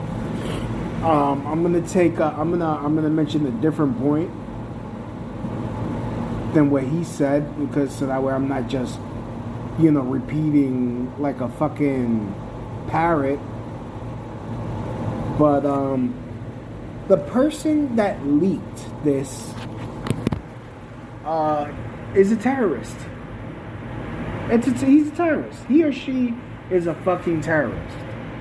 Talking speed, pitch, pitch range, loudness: 115 wpm, 135 Hz, 120-155 Hz, -22 LUFS